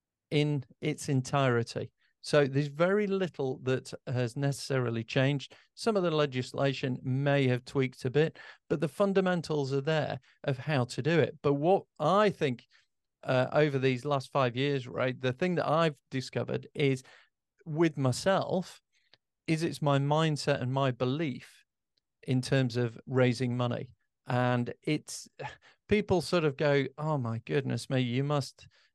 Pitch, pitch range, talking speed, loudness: 140 Hz, 130-155 Hz, 150 wpm, -30 LUFS